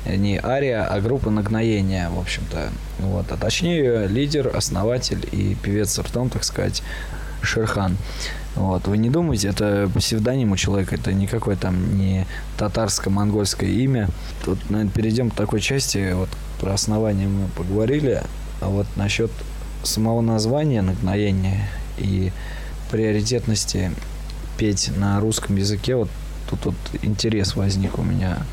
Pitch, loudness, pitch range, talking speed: 100 Hz, -22 LUFS, 95-110 Hz, 130 wpm